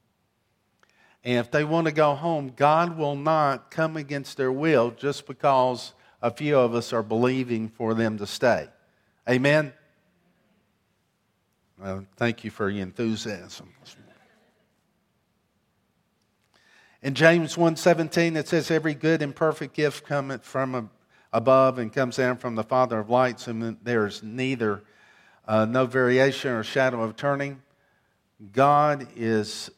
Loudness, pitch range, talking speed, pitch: -24 LUFS, 115-150 Hz, 135 wpm, 130 Hz